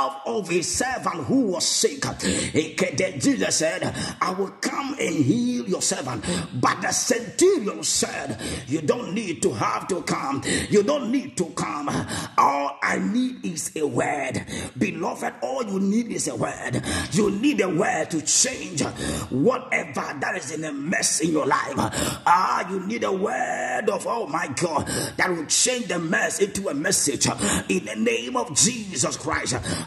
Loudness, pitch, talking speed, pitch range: -23 LUFS, 210 Hz, 165 wpm, 170-260 Hz